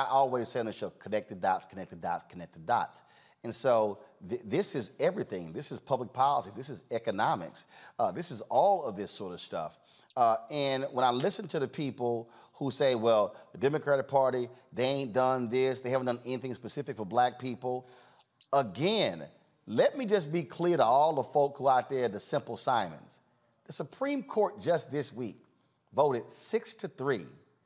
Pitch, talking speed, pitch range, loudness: 135 Hz, 190 wpm, 125-160 Hz, -31 LUFS